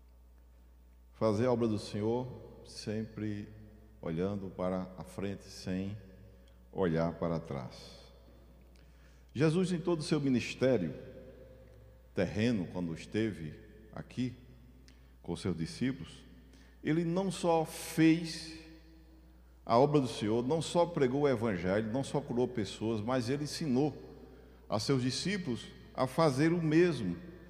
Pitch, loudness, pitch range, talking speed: 110 Hz, -33 LUFS, 85-135 Hz, 120 wpm